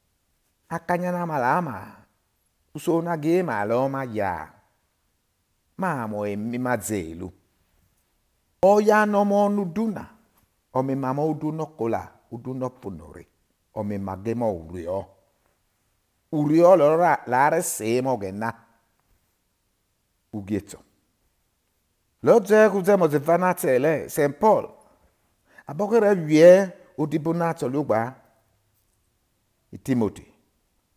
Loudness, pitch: -22 LUFS, 115 Hz